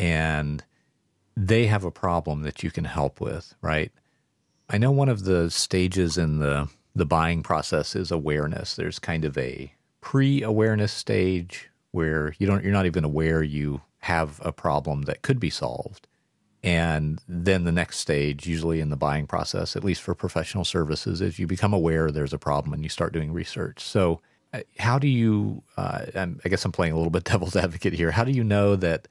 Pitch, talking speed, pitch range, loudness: 85 Hz, 190 wpm, 80-95 Hz, -25 LUFS